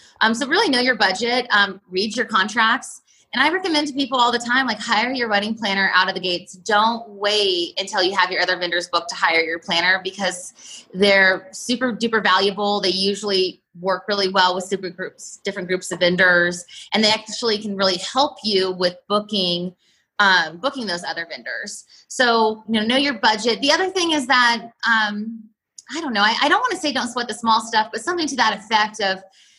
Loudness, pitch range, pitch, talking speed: -19 LUFS, 185-240 Hz, 210 Hz, 210 wpm